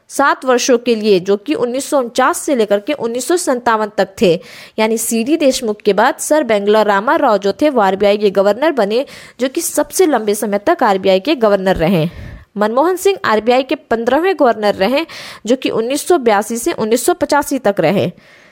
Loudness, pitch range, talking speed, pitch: -14 LUFS, 205-290 Hz, 150 wpm, 235 Hz